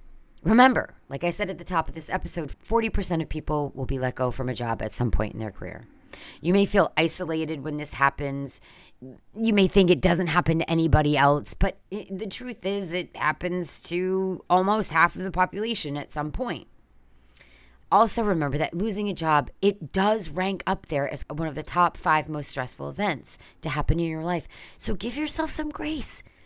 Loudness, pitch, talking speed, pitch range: -25 LUFS, 165 Hz, 195 wpm, 140-190 Hz